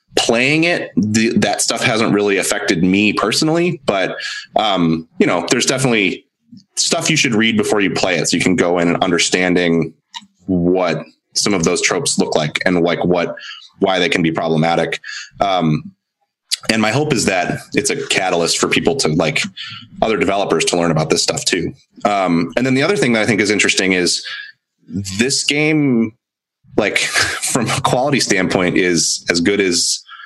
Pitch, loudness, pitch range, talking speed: 110 Hz, -15 LUFS, 90-145 Hz, 180 wpm